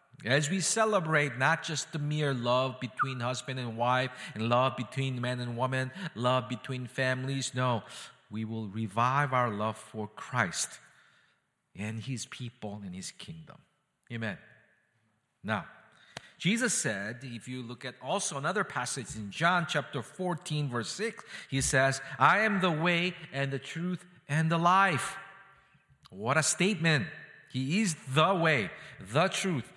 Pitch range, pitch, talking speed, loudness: 125-165 Hz, 135 Hz, 145 wpm, -30 LUFS